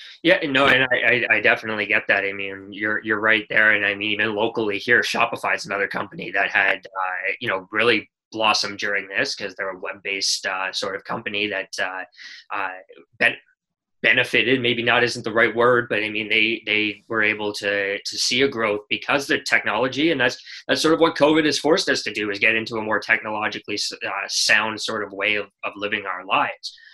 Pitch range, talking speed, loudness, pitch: 105-120 Hz, 210 wpm, -20 LUFS, 110 Hz